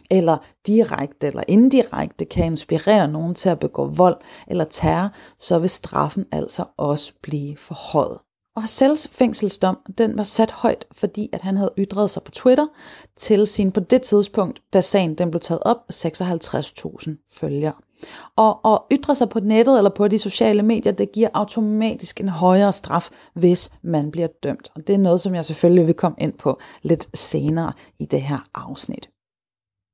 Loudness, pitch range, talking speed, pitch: -19 LUFS, 160-215 Hz, 170 wpm, 190 Hz